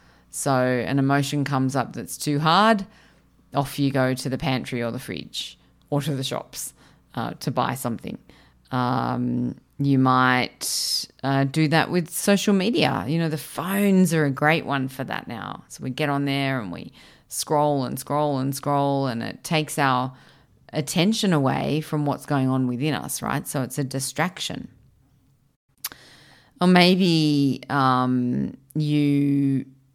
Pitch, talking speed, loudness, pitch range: 140 Hz, 155 wpm, -23 LUFS, 130-155 Hz